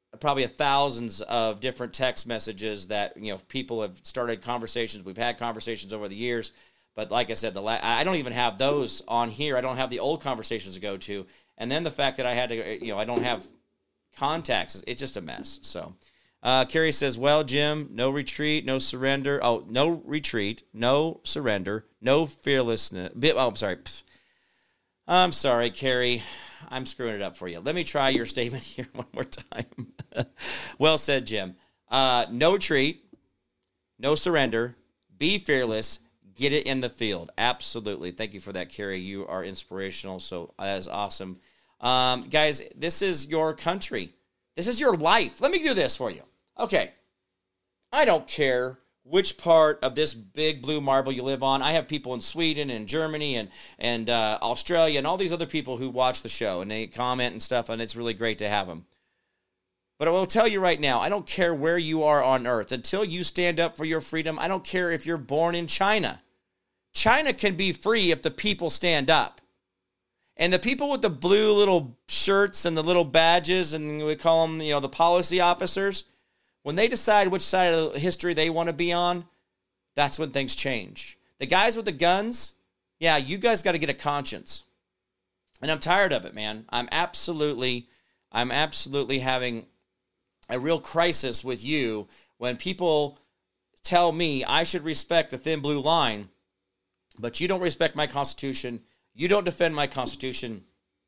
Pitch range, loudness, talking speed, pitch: 115-165 Hz, -25 LUFS, 190 wpm, 135 Hz